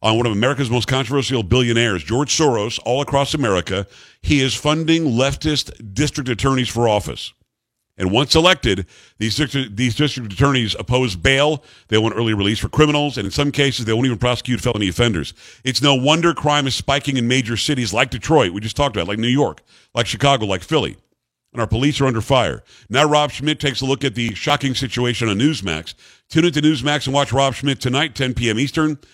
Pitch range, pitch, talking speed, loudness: 115-145 Hz, 130 Hz, 200 wpm, -18 LUFS